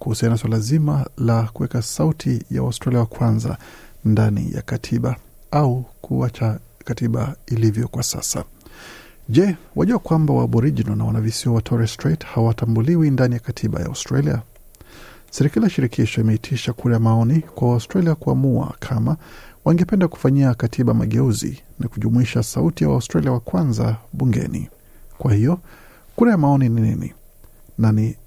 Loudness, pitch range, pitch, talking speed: -20 LUFS, 115-140 Hz, 120 Hz, 140 wpm